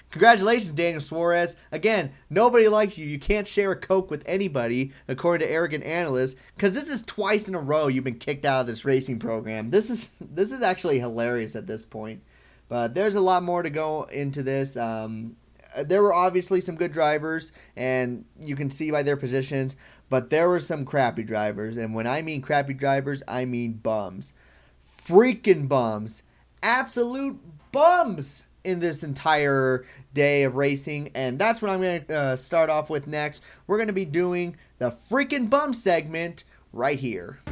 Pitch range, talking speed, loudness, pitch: 130-185 Hz, 175 wpm, -24 LUFS, 150 Hz